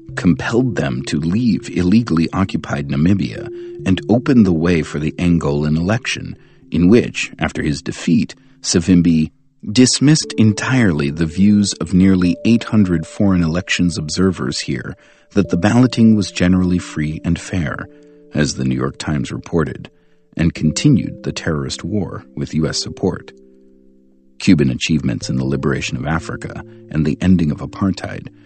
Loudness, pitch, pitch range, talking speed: -17 LUFS, 90 Hz, 75-110 Hz, 140 wpm